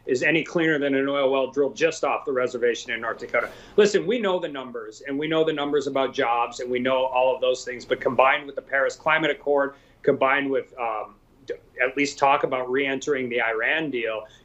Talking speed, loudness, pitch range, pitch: 220 wpm, -23 LUFS, 130-165 Hz, 140 Hz